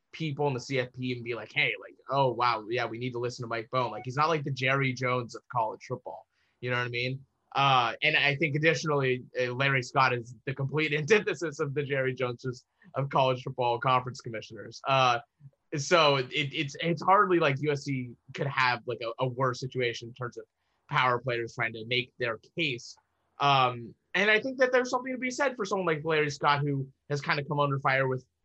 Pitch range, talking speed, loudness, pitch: 125-150 Hz, 215 wpm, -28 LUFS, 135 Hz